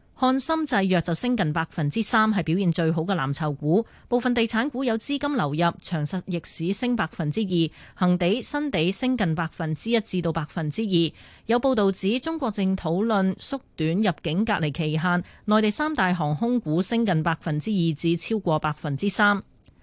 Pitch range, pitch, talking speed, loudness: 165-225 Hz, 185 Hz, 280 characters per minute, -24 LUFS